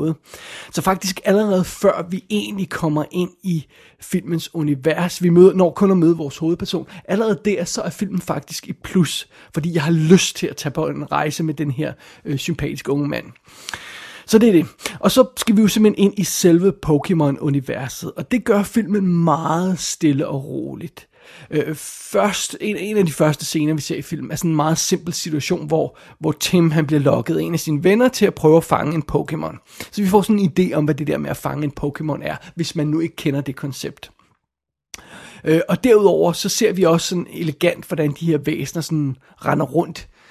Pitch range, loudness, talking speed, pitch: 155-190 Hz, -19 LUFS, 210 wpm, 165 Hz